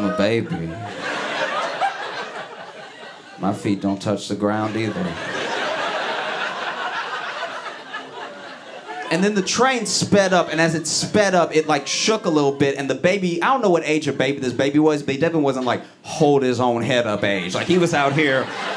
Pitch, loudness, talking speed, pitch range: 150 Hz, -20 LUFS, 180 wpm, 130-175 Hz